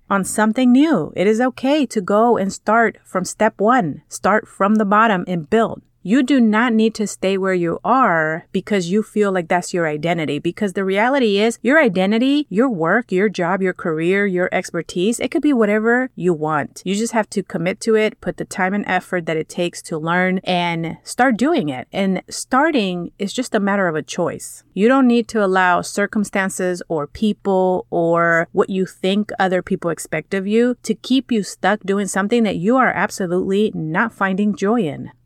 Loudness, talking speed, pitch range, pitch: -18 LUFS, 195 wpm, 180-225 Hz, 200 Hz